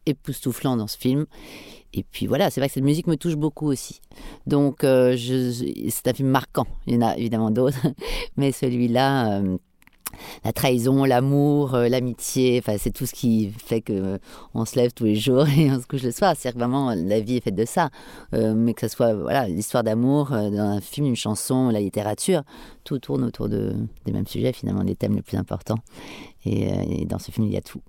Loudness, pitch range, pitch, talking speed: -23 LUFS, 110-140 Hz, 125 Hz, 225 wpm